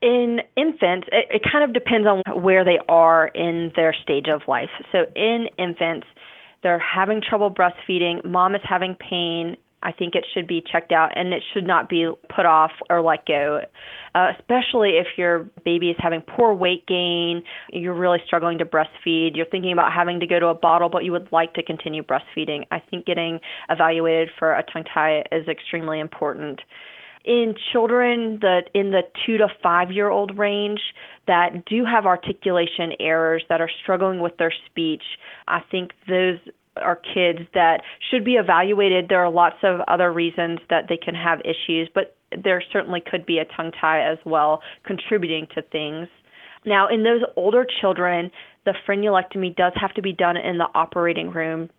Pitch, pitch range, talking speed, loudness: 175 Hz, 165-195 Hz, 180 wpm, -21 LUFS